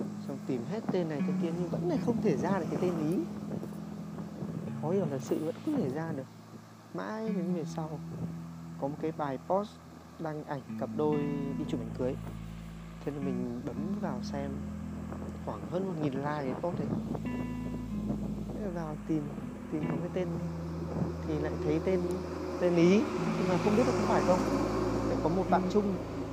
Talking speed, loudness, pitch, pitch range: 185 wpm, -33 LUFS, 170 Hz, 140-185 Hz